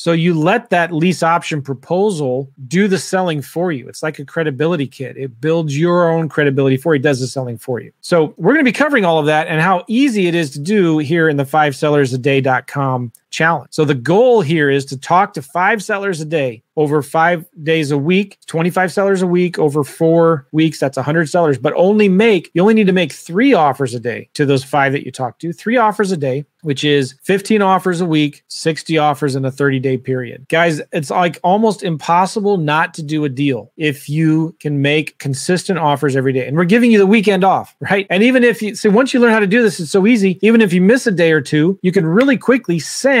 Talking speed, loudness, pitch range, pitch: 235 wpm, -15 LUFS, 145-190 Hz, 165 Hz